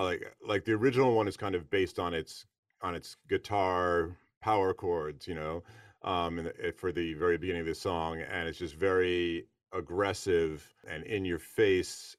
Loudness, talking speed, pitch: -32 LUFS, 180 wpm, 90 Hz